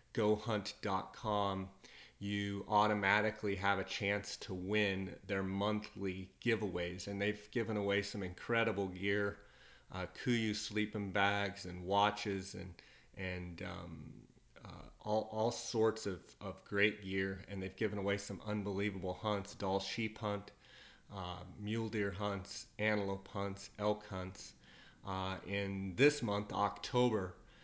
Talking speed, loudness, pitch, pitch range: 125 wpm, -38 LUFS, 100 Hz, 95-105 Hz